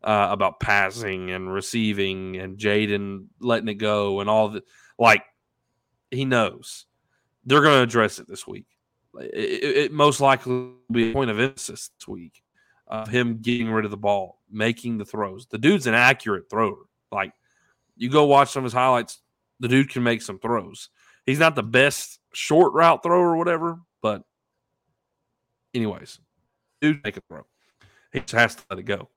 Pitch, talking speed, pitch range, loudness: 120 Hz, 180 wpm, 105-135 Hz, -22 LUFS